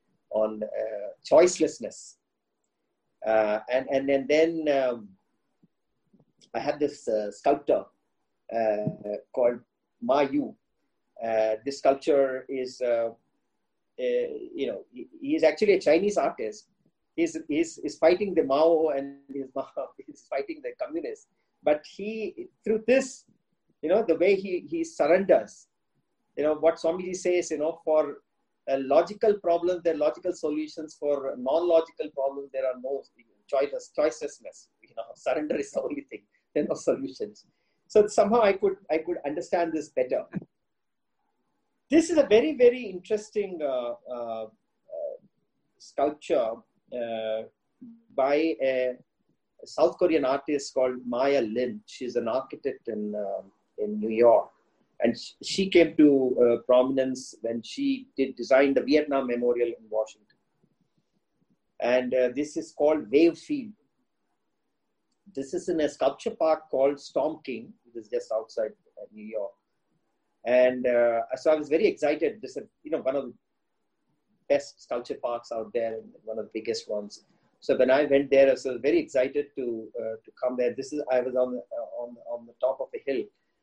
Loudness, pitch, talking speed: -27 LUFS, 150 Hz, 155 wpm